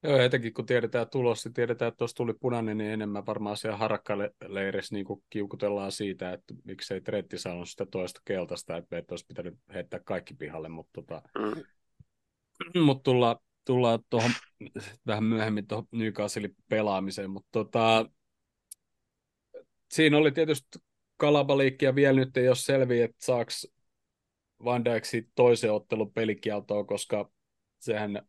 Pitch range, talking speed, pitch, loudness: 105-125 Hz, 130 wpm, 110 Hz, -29 LUFS